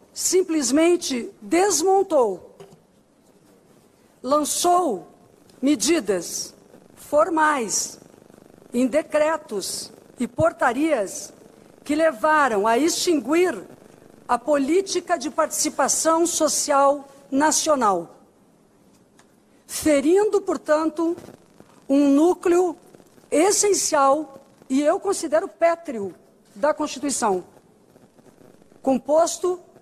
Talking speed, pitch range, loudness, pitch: 60 wpm, 275-335 Hz, -21 LUFS, 305 Hz